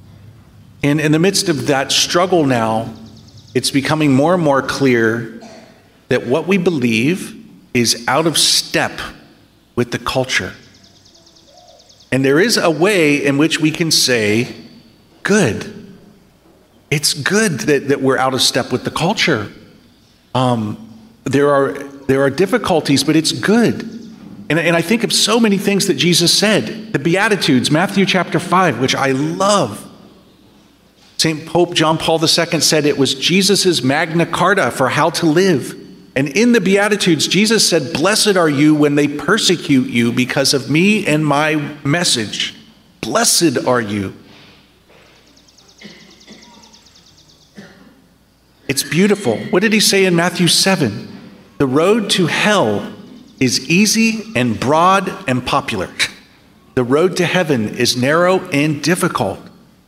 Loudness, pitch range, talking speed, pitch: -14 LUFS, 130-180 Hz, 140 wpm, 155 Hz